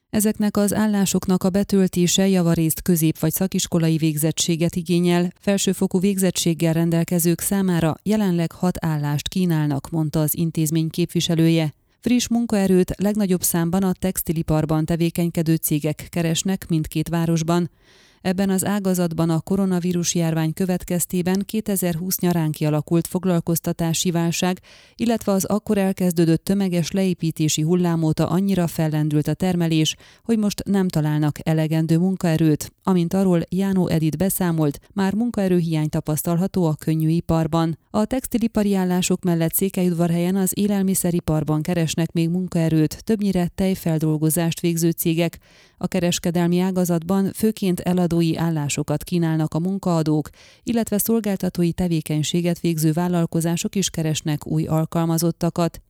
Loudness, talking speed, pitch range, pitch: -21 LUFS, 115 wpm, 160-190 Hz, 175 Hz